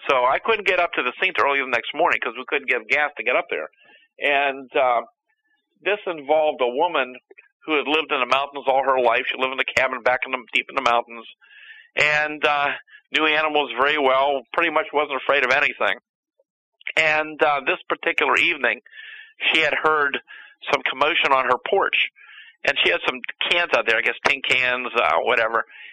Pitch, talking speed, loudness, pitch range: 150 Hz, 200 wpm, -20 LUFS, 130-175 Hz